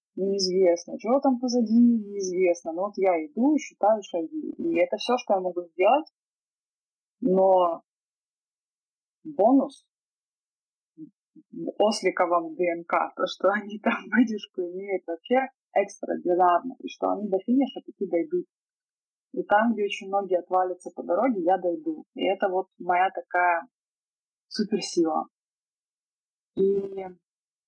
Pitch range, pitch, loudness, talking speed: 180-260 Hz, 200 Hz, -25 LUFS, 120 wpm